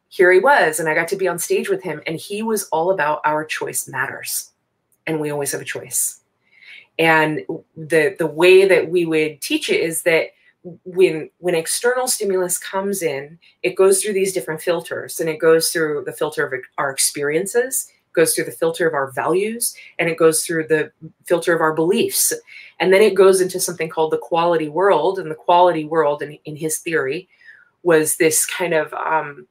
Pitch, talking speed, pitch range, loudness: 170 Hz, 195 wpm, 160-190 Hz, -18 LUFS